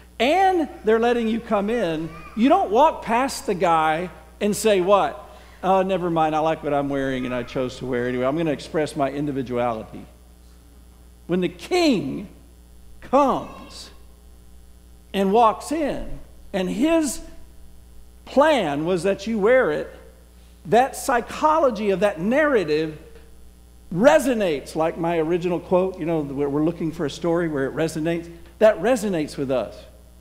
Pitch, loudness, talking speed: 165 Hz, -21 LUFS, 150 wpm